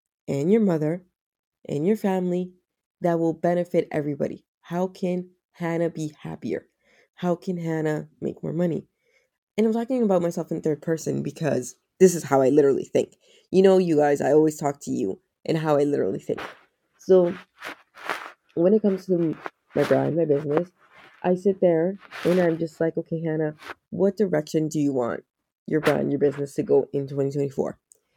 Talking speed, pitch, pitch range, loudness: 175 wpm, 165 Hz, 150-185 Hz, -24 LUFS